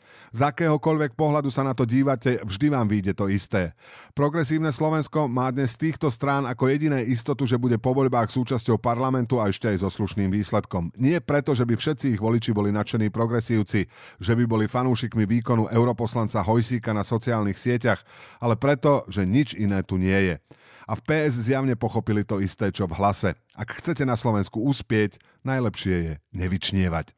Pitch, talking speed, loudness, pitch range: 120 Hz, 175 wpm, -24 LUFS, 105-135 Hz